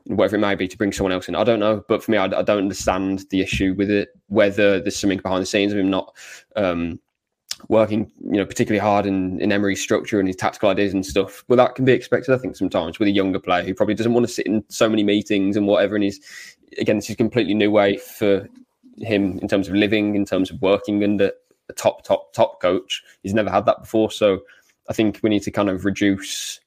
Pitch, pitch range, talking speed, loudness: 100 Hz, 95-110 Hz, 250 wpm, -20 LUFS